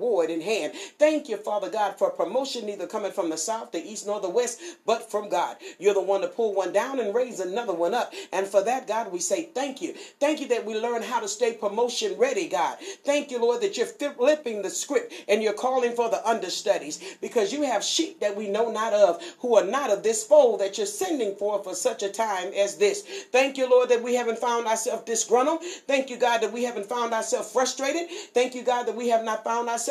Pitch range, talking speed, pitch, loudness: 215-300 Hz, 235 wpm, 240 Hz, -25 LUFS